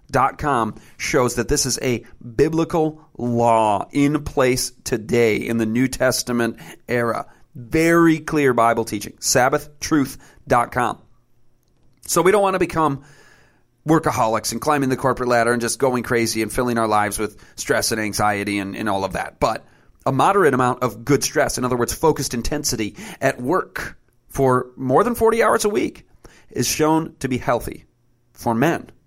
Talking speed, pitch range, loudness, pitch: 165 wpm, 115-150 Hz, -20 LUFS, 125 Hz